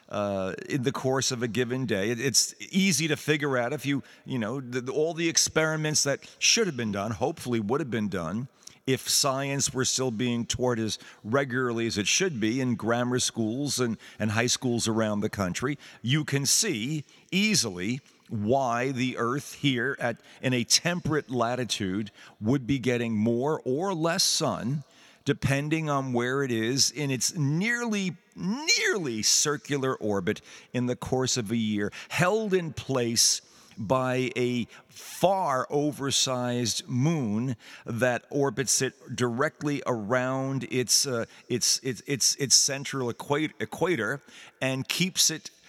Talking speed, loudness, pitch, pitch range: 150 wpm, -26 LUFS, 130 Hz, 115-145 Hz